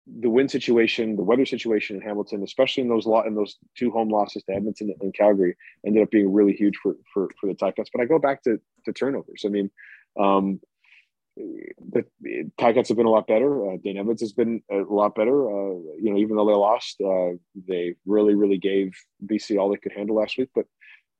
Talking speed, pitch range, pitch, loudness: 220 wpm, 100-115 Hz, 105 Hz, -23 LUFS